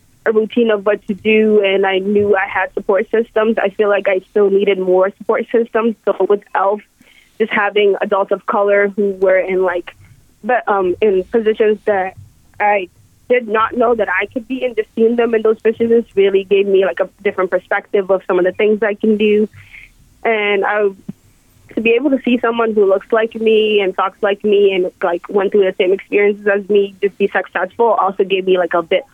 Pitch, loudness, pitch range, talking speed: 205 Hz, -15 LUFS, 195-220 Hz, 210 wpm